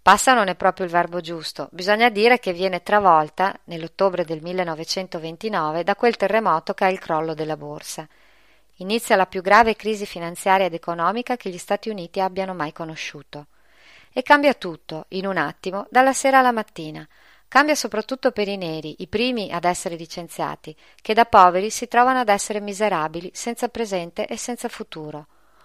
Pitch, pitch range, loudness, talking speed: 190 Hz, 170-220 Hz, -21 LUFS, 170 wpm